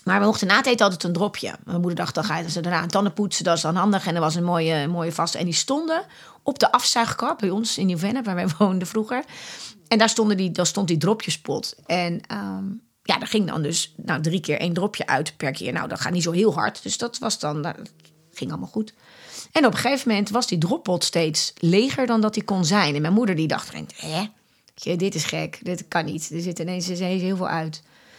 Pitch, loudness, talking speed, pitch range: 180 Hz, -23 LUFS, 245 wpm, 165-210 Hz